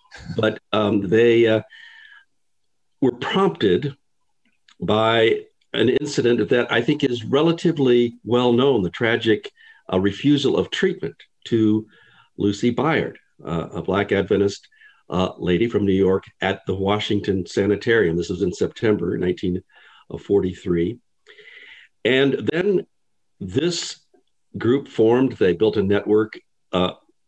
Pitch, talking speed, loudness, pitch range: 110 Hz, 115 wpm, -21 LUFS, 100-140 Hz